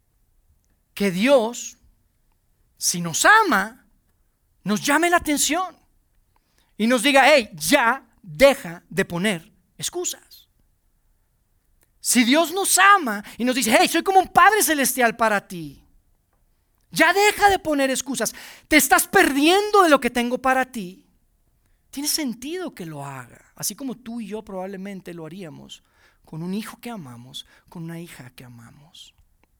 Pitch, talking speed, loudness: 220 Hz, 140 wpm, -19 LUFS